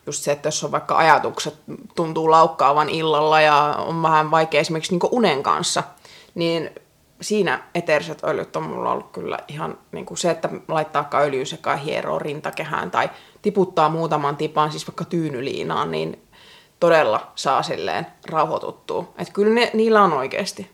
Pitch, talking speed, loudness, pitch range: 160 Hz, 155 wpm, -20 LUFS, 150-185 Hz